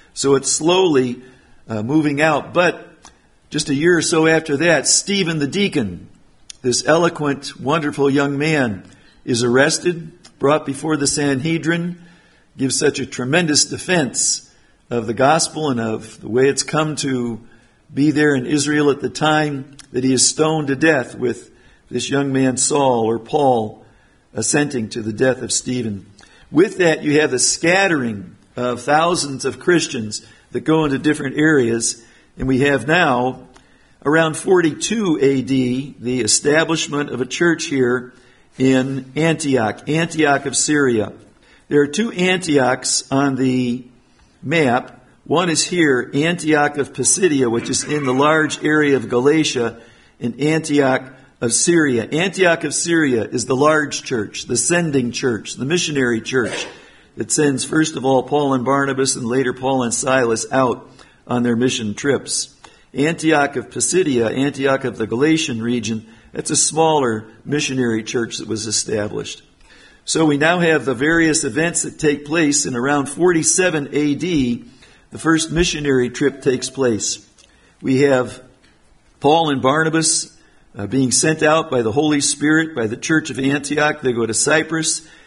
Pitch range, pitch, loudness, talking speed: 125-155 Hz, 140 Hz, -17 LUFS, 150 wpm